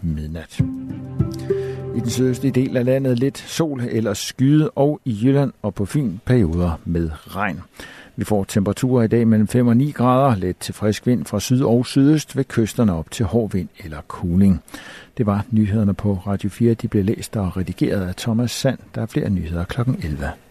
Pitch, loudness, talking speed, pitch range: 115 Hz, -20 LUFS, 195 wpm, 100-130 Hz